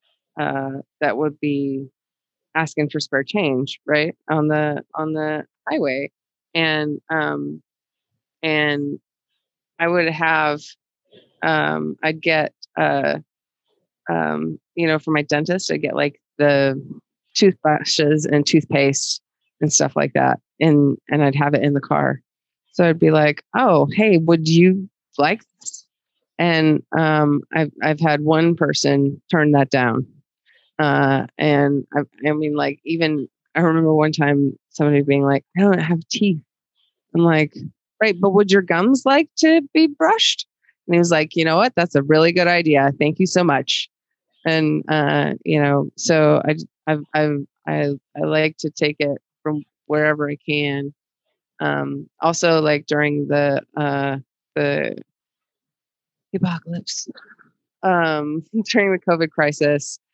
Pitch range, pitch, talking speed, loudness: 145-165 Hz, 150 Hz, 145 wpm, -19 LUFS